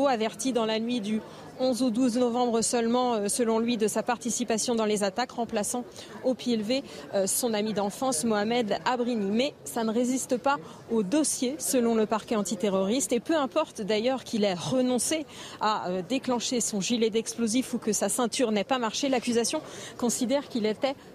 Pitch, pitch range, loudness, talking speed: 240 Hz, 220-255 Hz, -27 LUFS, 175 wpm